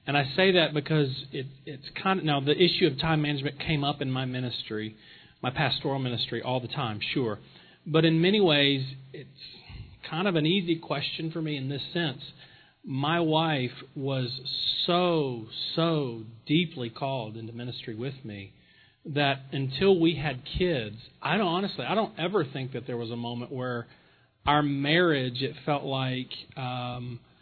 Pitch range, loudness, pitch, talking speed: 125-160 Hz, -28 LUFS, 140 Hz, 170 wpm